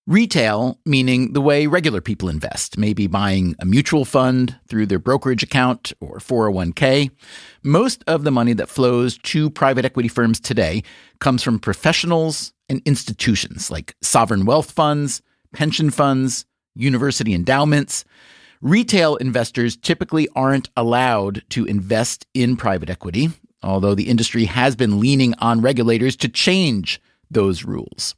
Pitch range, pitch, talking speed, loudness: 110-145 Hz, 125 Hz, 135 wpm, -18 LUFS